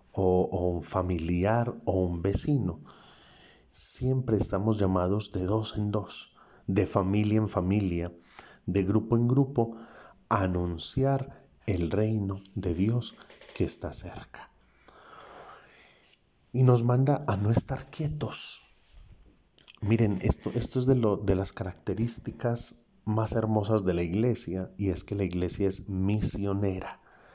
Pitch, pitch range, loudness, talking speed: 105 Hz, 95-115 Hz, -29 LUFS, 130 wpm